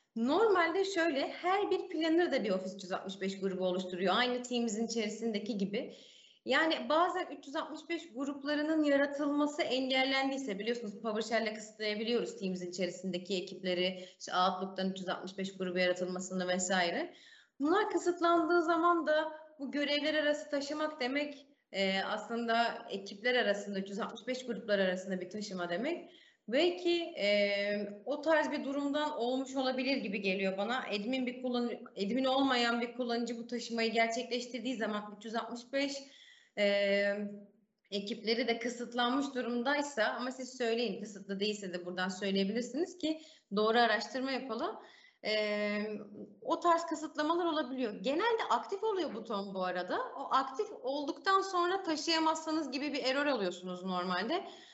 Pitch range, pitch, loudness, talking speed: 205-300 Hz, 245 Hz, -34 LUFS, 120 wpm